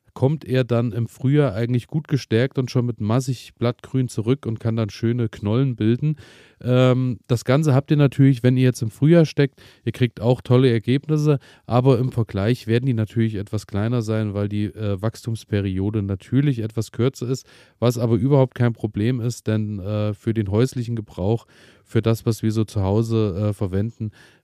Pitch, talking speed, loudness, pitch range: 115 Hz, 175 wpm, -21 LUFS, 110-130 Hz